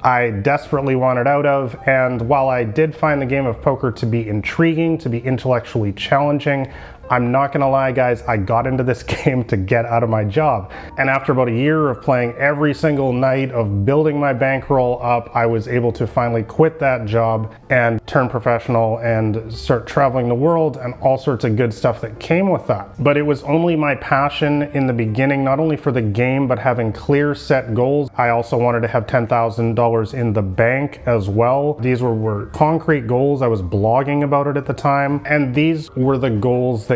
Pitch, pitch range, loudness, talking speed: 130 Hz, 115-145 Hz, -17 LUFS, 205 wpm